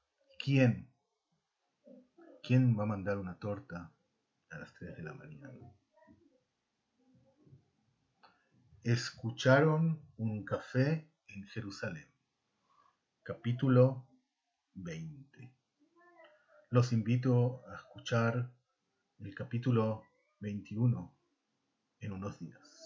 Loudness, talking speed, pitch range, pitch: -34 LUFS, 80 wpm, 115-155 Hz, 125 Hz